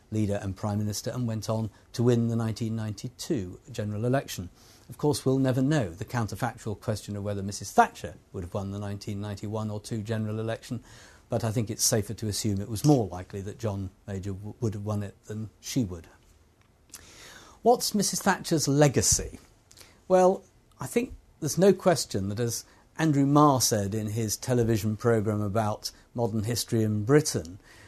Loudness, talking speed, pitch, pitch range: -28 LUFS, 170 wpm, 110 Hz, 105-125 Hz